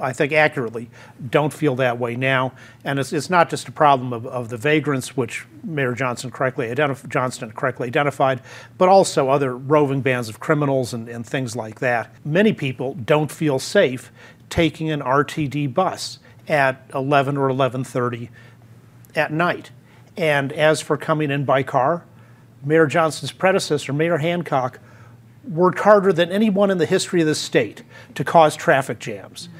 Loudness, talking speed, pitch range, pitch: -20 LUFS, 160 wpm, 125-155 Hz, 140 Hz